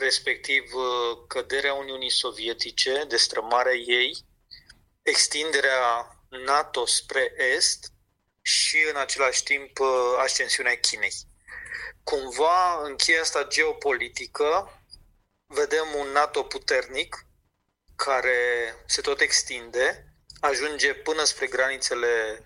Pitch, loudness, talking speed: 155 Hz, -24 LUFS, 90 wpm